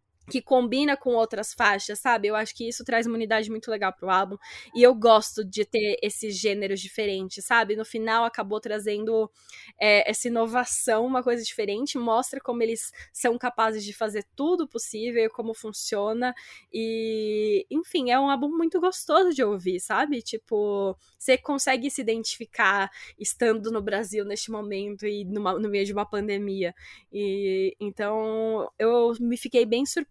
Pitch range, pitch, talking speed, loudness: 210-245 Hz, 225 Hz, 165 wpm, -25 LUFS